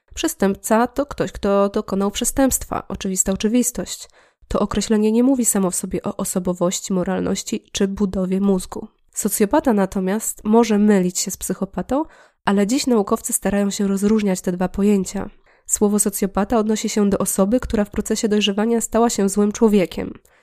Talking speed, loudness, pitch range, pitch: 150 wpm, -19 LUFS, 195-220 Hz, 205 Hz